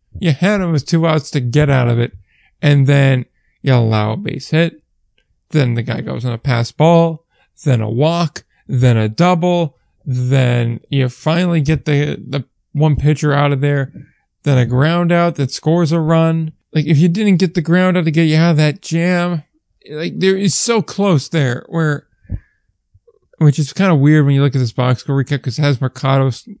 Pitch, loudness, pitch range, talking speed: 150 Hz, -15 LUFS, 130-165 Hz, 205 wpm